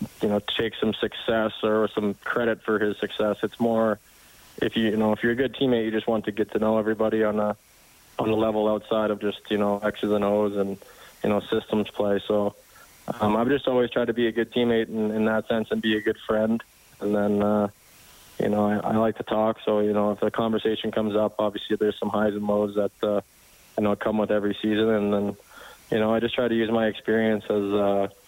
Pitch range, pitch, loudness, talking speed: 105-110 Hz, 105 Hz, -25 LUFS, 240 wpm